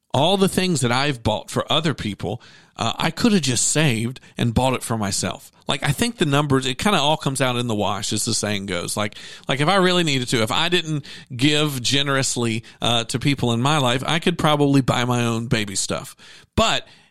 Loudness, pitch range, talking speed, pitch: -20 LUFS, 115-155 Hz, 235 wpm, 135 Hz